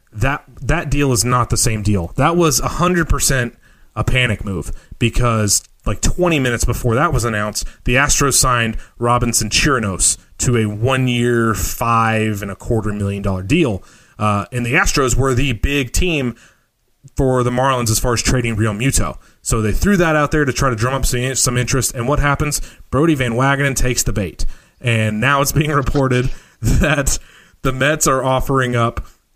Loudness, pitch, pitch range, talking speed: -17 LUFS, 125 Hz, 110-135 Hz, 180 wpm